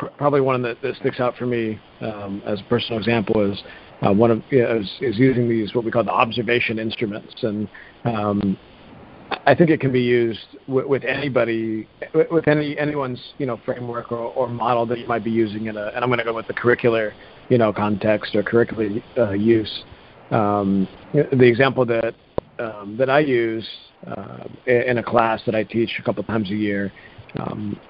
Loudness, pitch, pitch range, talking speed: -21 LUFS, 115 Hz, 110-125 Hz, 195 wpm